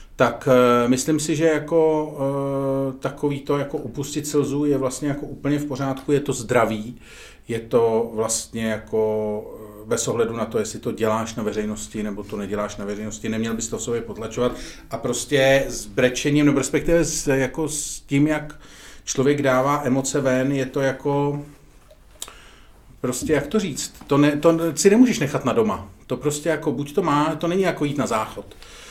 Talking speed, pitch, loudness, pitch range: 180 wpm, 135 Hz, -22 LUFS, 115-145 Hz